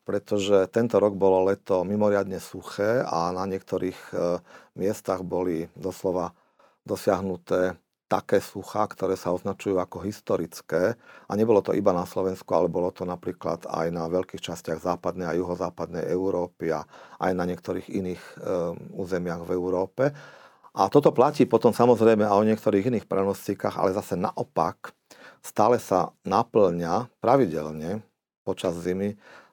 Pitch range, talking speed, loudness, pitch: 90-100 Hz, 140 wpm, -26 LUFS, 95 Hz